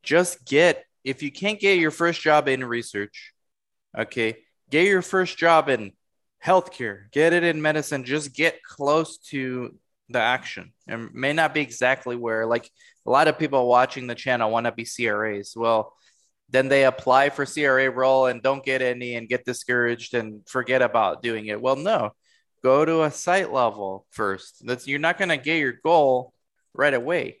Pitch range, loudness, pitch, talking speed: 120-155 Hz, -22 LUFS, 130 Hz, 180 wpm